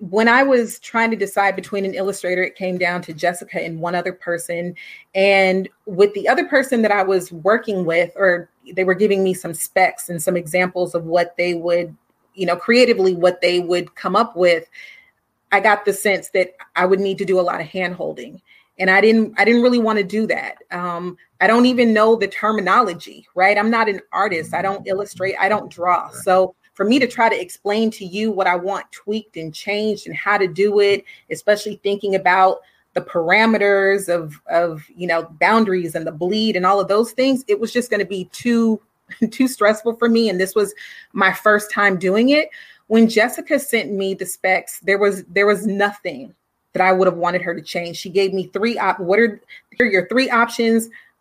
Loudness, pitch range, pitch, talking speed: -18 LUFS, 180-220 Hz, 195 Hz, 215 wpm